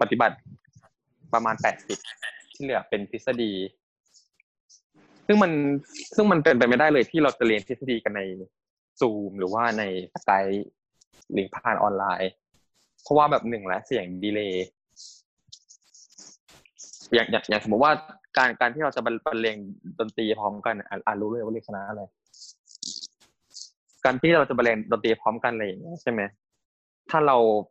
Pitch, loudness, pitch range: 115 Hz, -25 LUFS, 100-130 Hz